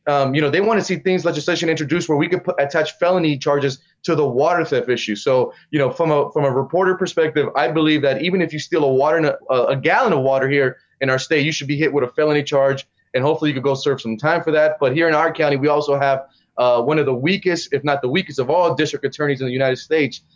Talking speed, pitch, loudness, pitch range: 270 wpm, 150 Hz, -18 LUFS, 135-165 Hz